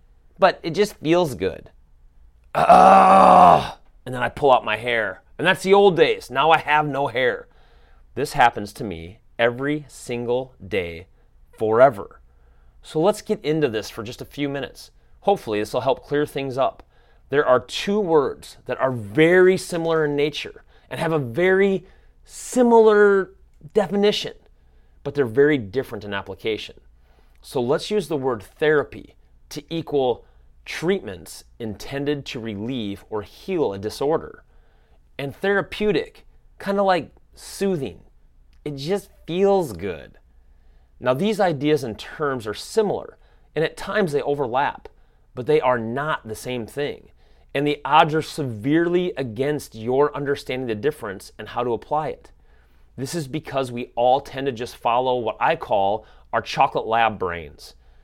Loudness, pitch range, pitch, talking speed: -21 LUFS, 105-170 Hz, 140 Hz, 150 wpm